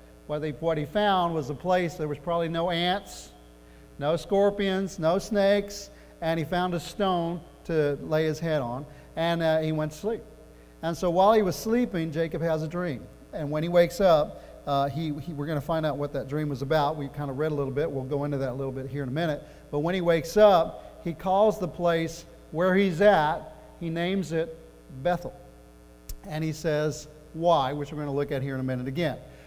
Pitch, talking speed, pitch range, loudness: 160 Hz, 225 wpm, 145-175 Hz, -27 LUFS